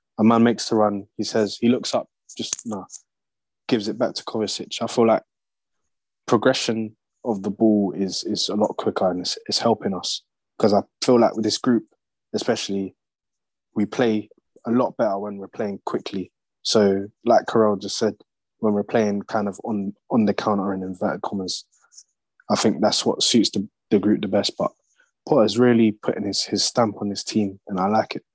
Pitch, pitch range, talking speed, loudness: 105 Hz, 100-110 Hz, 200 wpm, -22 LUFS